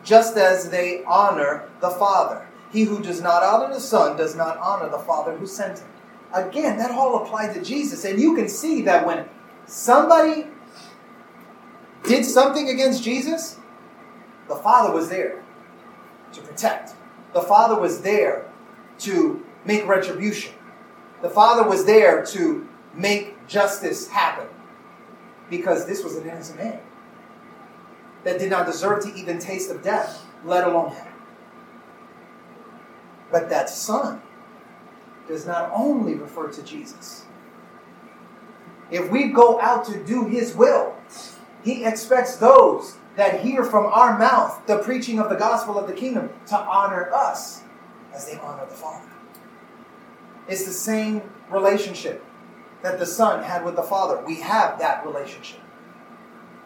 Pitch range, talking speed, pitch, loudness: 195-240 Hz, 140 wpm, 220 Hz, -20 LUFS